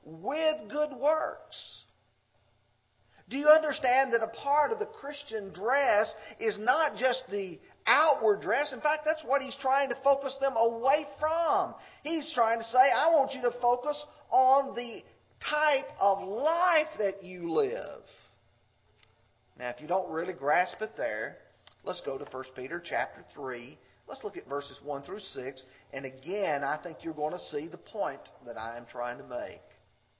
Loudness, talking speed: -30 LUFS, 170 wpm